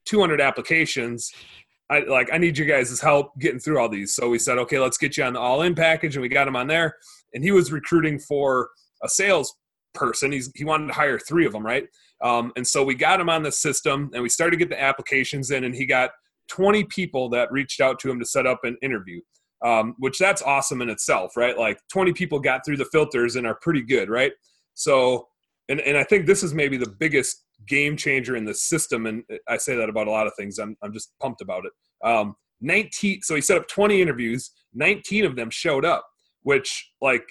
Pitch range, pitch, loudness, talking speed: 125-160 Hz, 140 Hz, -22 LUFS, 230 wpm